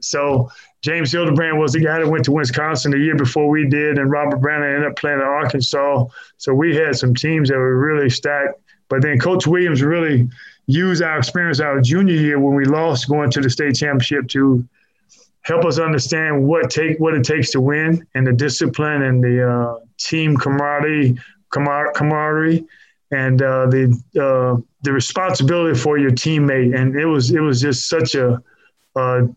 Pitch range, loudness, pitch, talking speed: 130-155 Hz, -17 LUFS, 145 Hz, 185 wpm